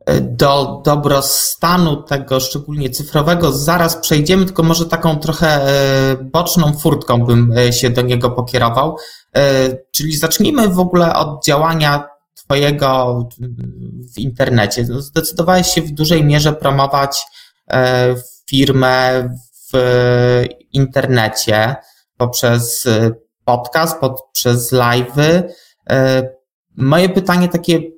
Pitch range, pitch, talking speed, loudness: 125-160 Hz, 135 Hz, 90 wpm, -14 LUFS